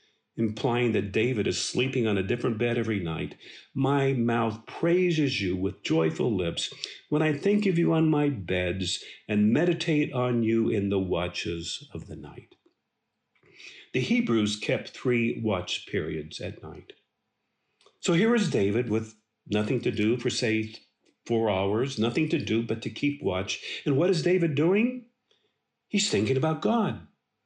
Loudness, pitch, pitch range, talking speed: -27 LUFS, 120 Hz, 110-160 Hz, 155 wpm